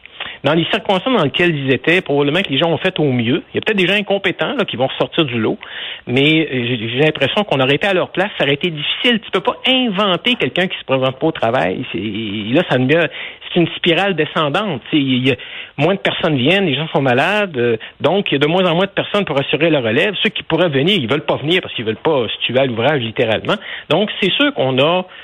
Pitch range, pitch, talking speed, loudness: 135-185 Hz, 160 Hz, 260 wpm, -16 LUFS